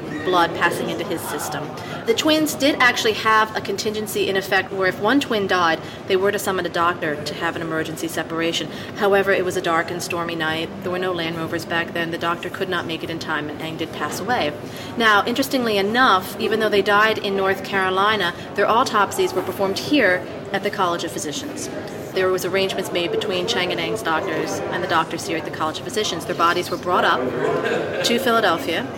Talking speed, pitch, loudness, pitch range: 215 wpm, 185 Hz, -21 LUFS, 170-205 Hz